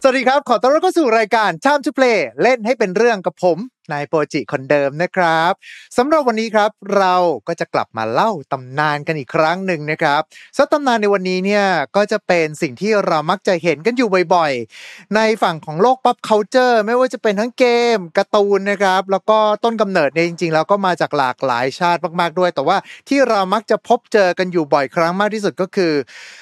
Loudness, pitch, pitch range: -16 LUFS, 200 Hz, 170-230 Hz